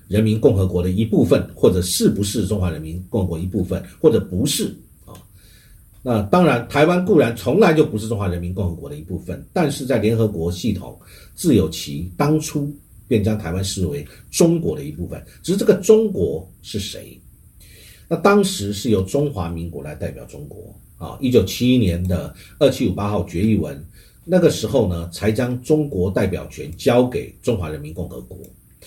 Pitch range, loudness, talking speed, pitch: 90-140 Hz, -19 LUFS, 285 characters per minute, 105 Hz